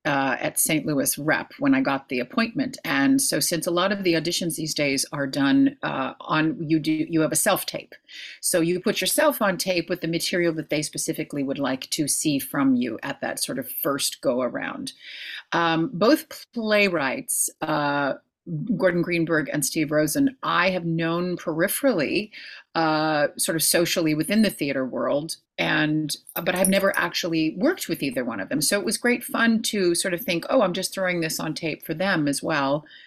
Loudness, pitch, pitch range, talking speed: -23 LUFS, 175 Hz, 155-220 Hz, 195 wpm